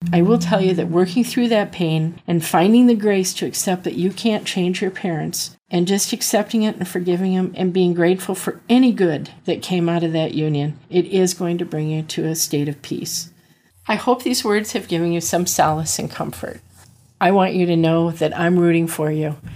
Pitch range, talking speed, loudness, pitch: 165-195 Hz, 220 wpm, -19 LUFS, 180 Hz